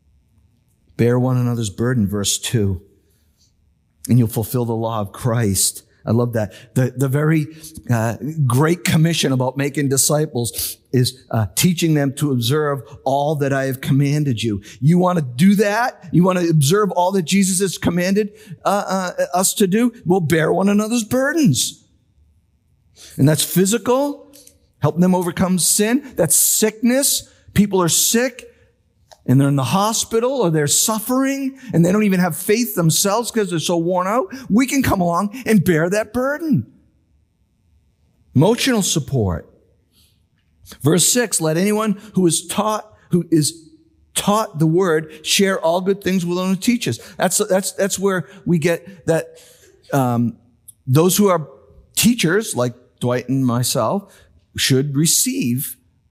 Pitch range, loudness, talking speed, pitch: 125-195 Hz, -18 LUFS, 150 wpm, 160 Hz